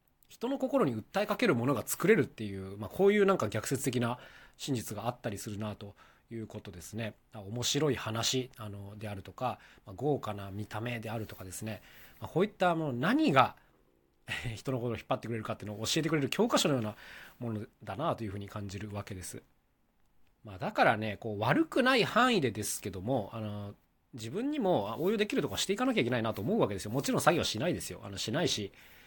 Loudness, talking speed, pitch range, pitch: -32 LUFS, 430 characters per minute, 105-135 Hz, 115 Hz